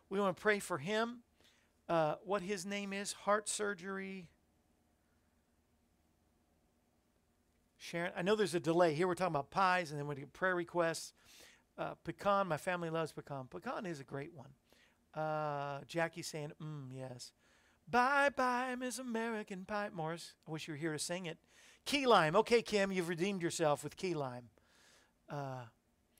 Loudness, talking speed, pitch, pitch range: -37 LUFS, 165 wpm, 165 Hz, 140-200 Hz